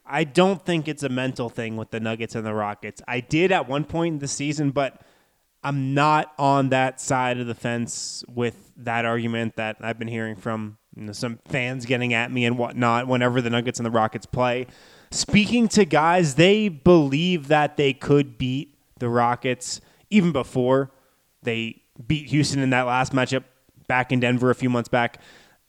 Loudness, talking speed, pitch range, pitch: -23 LUFS, 190 wpm, 120-145 Hz, 130 Hz